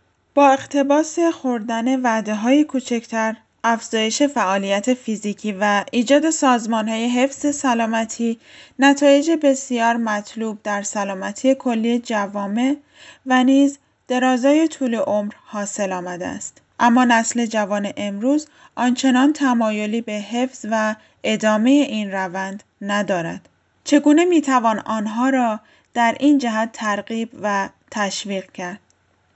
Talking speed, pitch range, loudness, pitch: 110 wpm, 210-270 Hz, -19 LUFS, 230 Hz